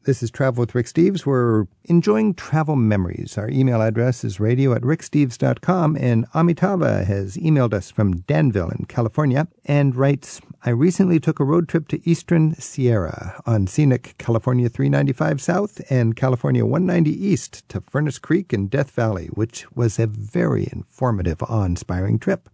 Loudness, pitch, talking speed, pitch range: -20 LUFS, 130 Hz, 155 wpm, 115-155 Hz